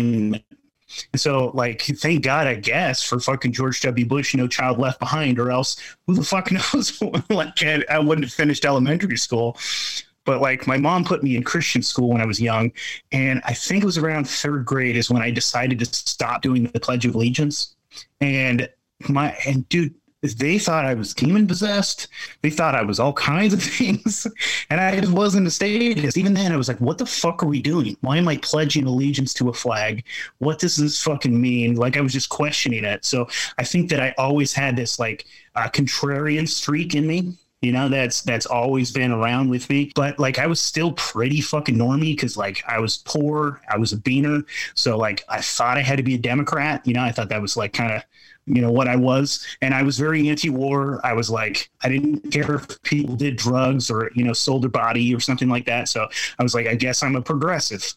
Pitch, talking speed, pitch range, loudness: 135 Hz, 220 wpm, 125-150 Hz, -21 LUFS